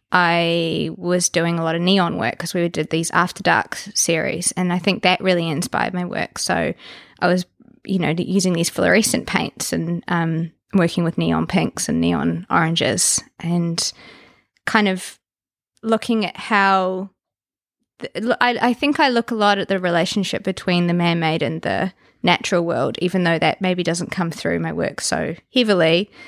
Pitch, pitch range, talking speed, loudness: 175 Hz, 165-195 Hz, 175 wpm, -19 LUFS